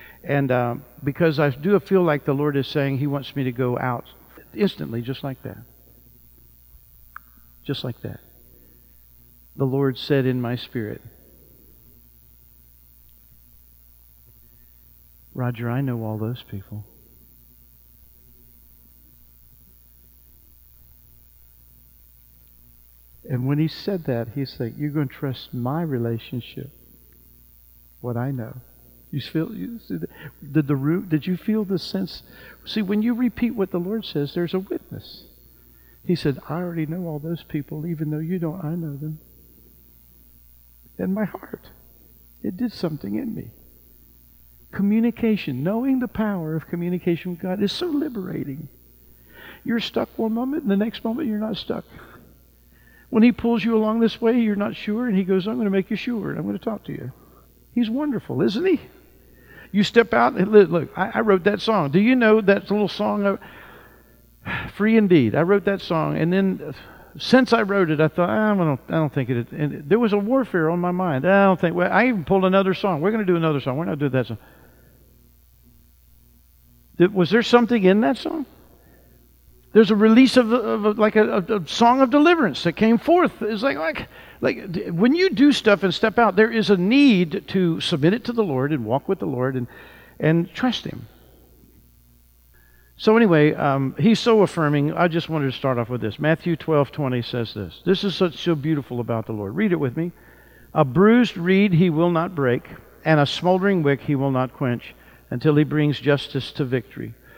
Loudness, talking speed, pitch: -21 LUFS, 175 wpm, 150 Hz